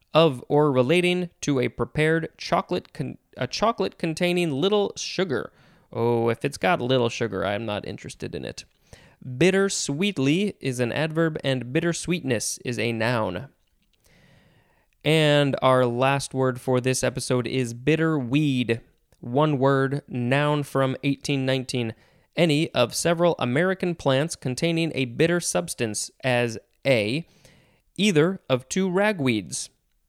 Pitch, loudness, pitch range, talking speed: 135 Hz, -24 LUFS, 125-165 Hz, 130 wpm